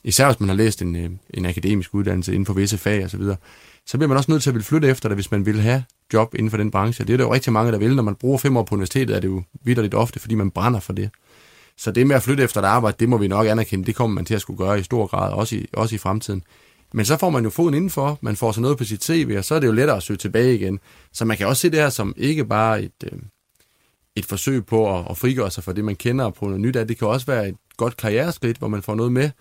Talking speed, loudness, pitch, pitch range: 310 wpm, -20 LUFS, 110 Hz, 100-125 Hz